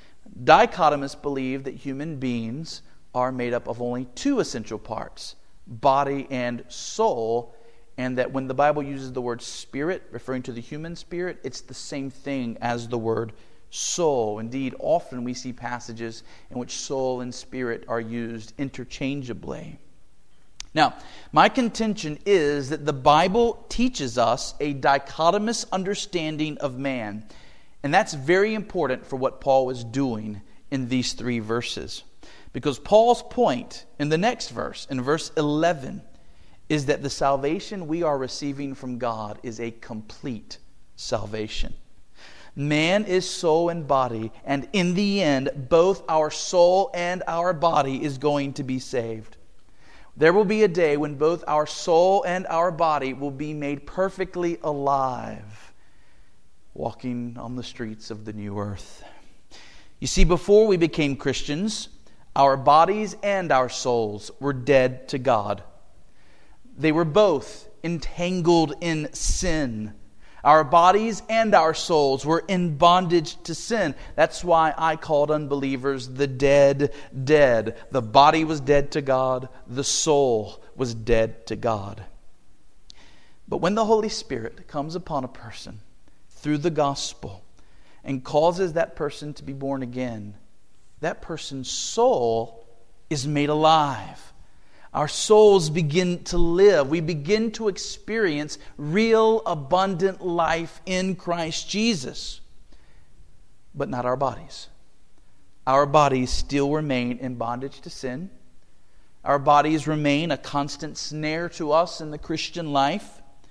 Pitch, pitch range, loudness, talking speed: 140 Hz, 120-165 Hz, -23 LUFS, 140 wpm